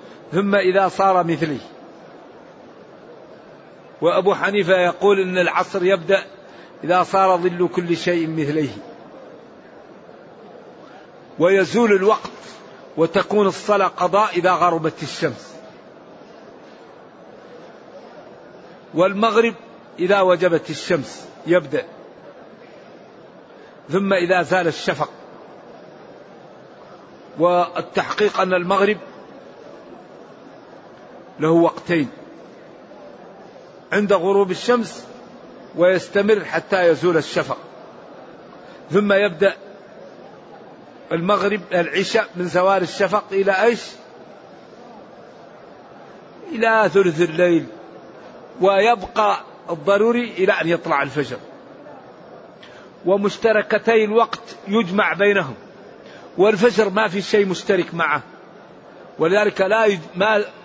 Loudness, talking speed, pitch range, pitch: -18 LUFS, 75 wpm, 175-205 Hz, 195 Hz